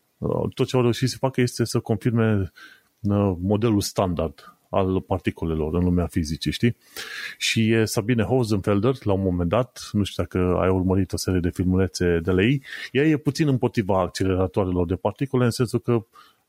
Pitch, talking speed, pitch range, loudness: 105 Hz, 170 wpm, 95-120 Hz, -23 LUFS